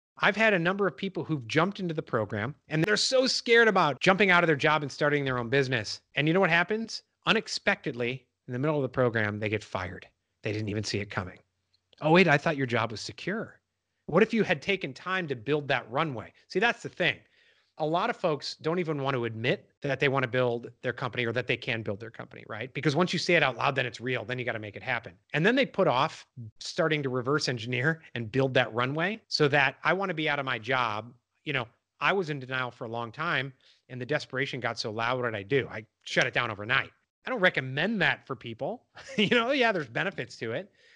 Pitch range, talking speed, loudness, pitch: 120-170 Hz, 250 wpm, -28 LUFS, 140 Hz